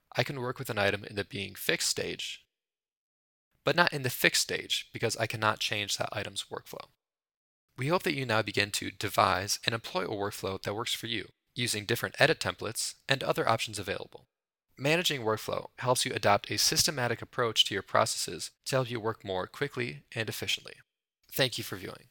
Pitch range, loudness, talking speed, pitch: 105-135 Hz, -30 LUFS, 195 wpm, 115 Hz